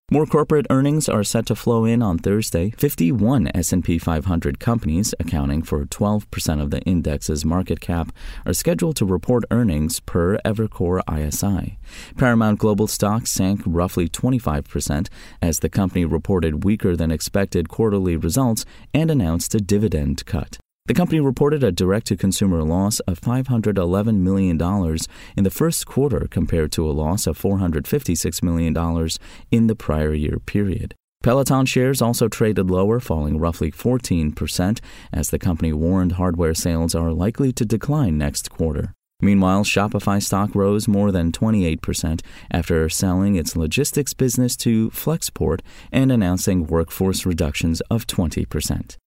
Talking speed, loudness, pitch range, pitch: 145 wpm, -20 LUFS, 80-115 Hz, 95 Hz